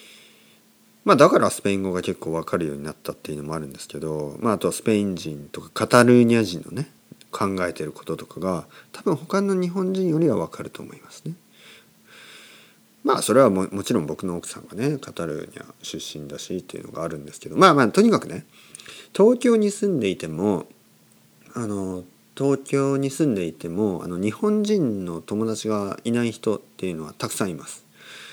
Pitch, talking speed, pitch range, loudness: 100 Hz, 380 characters per minute, 85-135 Hz, -23 LUFS